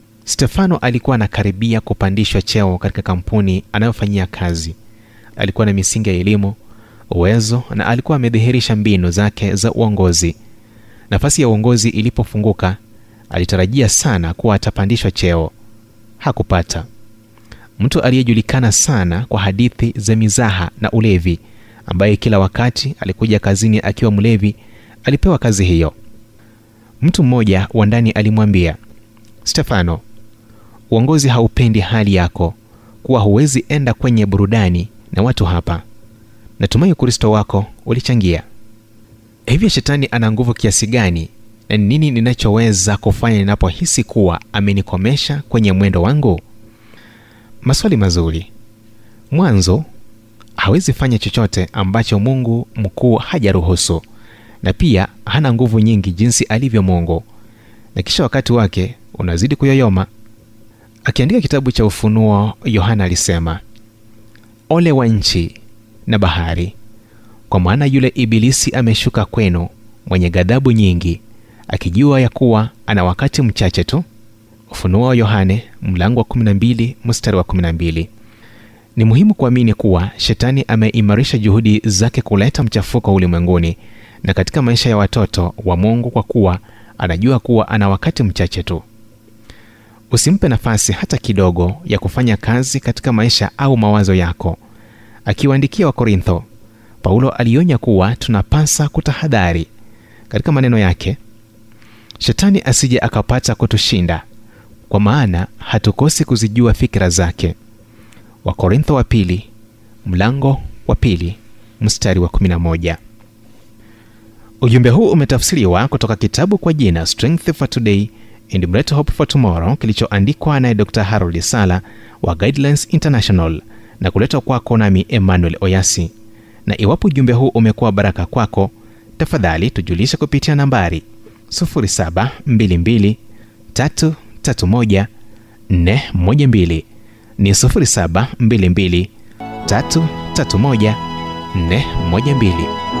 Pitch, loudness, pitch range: 110 Hz, -14 LUFS, 100-120 Hz